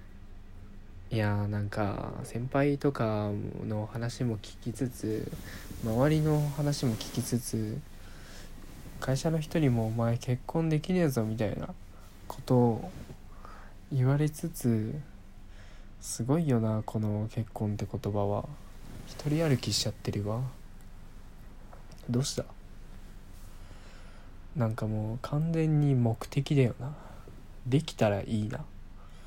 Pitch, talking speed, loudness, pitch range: 110 Hz, 205 characters per minute, -31 LUFS, 100-130 Hz